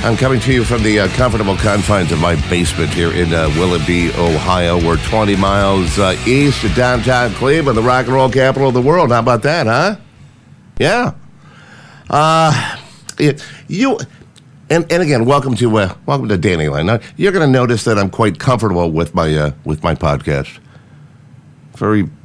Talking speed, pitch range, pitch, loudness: 180 wpm, 85-130 Hz, 110 Hz, -14 LUFS